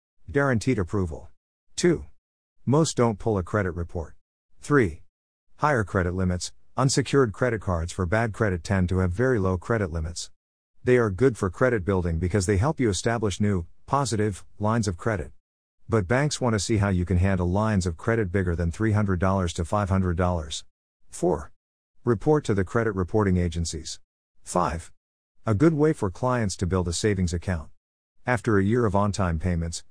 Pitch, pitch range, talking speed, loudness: 95 Hz, 85-115 Hz, 170 wpm, -25 LUFS